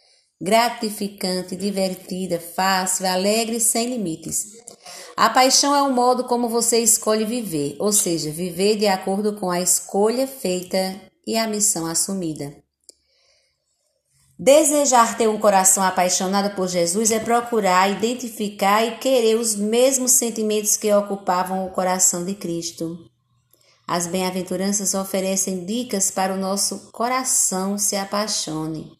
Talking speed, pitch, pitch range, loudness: 125 wpm, 200 Hz, 185-225 Hz, -19 LUFS